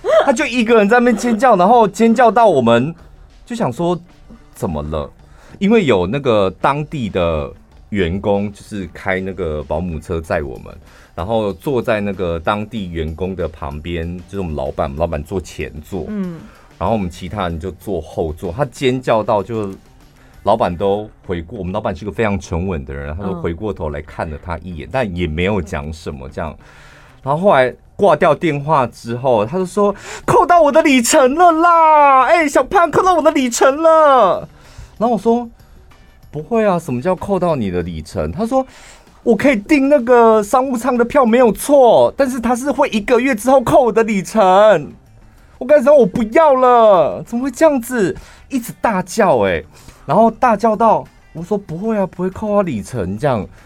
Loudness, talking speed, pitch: -15 LUFS, 265 characters per minute, 185 Hz